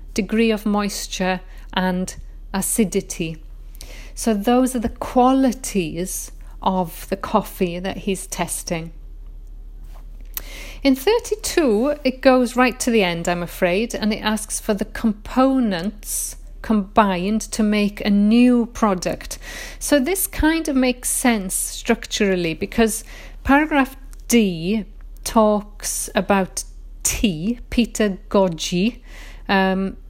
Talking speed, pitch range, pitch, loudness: 110 wpm, 190-245 Hz, 215 Hz, -20 LUFS